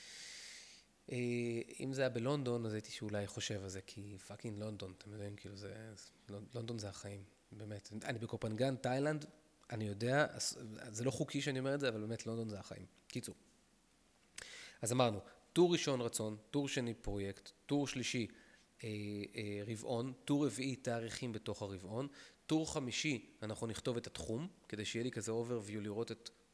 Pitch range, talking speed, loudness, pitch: 105-130 Hz, 160 wpm, -41 LUFS, 115 Hz